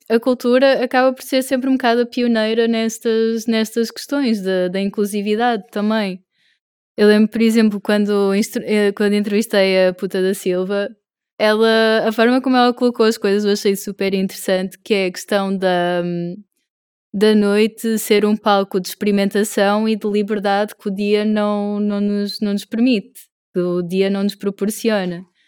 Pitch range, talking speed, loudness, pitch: 200-225 Hz, 165 wpm, -17 LUFS, 210 Hz